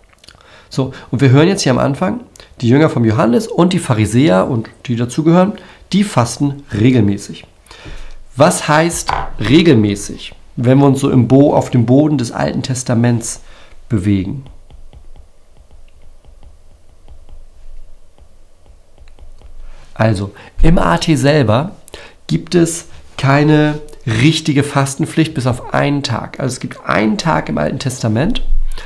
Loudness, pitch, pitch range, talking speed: -14 LUFS, 120 Hz, 90-145 Hz, 125 wpm